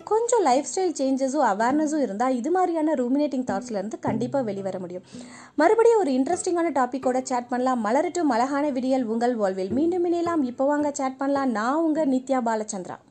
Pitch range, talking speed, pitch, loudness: 245-310 Hz, 150 wpm, 265 Hz, -24 LUFS